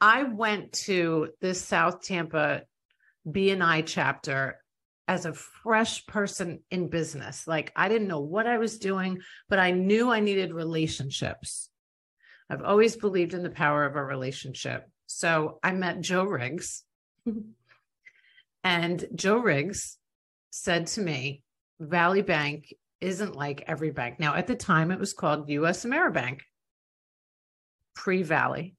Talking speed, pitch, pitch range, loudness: 135 wpm, 180 Hz, 155-200 Hz, -27 LUFS